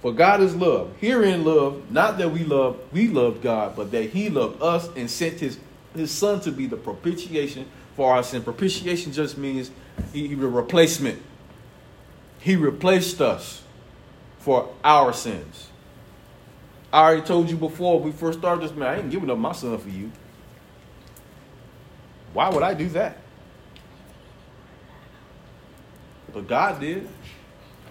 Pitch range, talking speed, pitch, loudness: 130-175 Hz, 145 wpm, 155 Hz, -22 LUFS